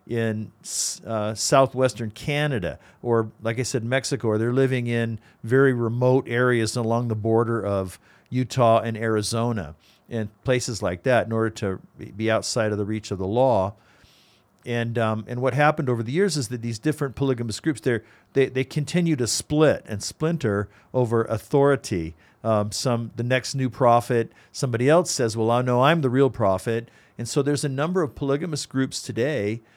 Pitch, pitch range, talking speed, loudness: 120 Hz, 110-135 Hz, 175 wpm, -23 LUFS